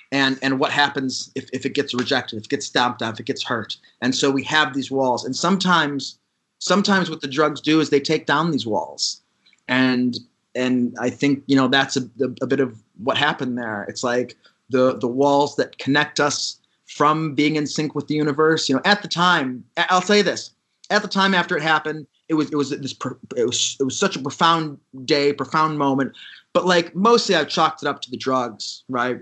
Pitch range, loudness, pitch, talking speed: 130-155 Hz, -20 LUFS, 140 Hz, 220 wpm